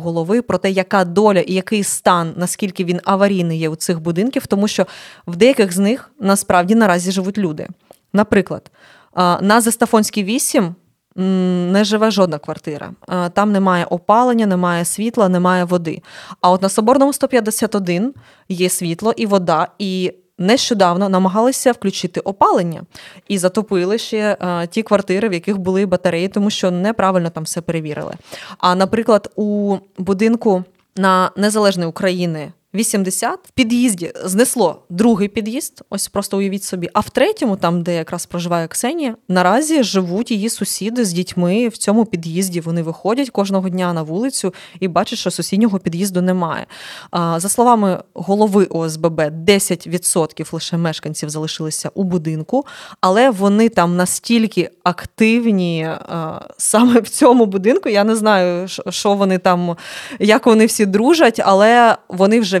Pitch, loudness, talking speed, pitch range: 195 Hz, -16 LUFS, 140 wpm, 180-220 Hz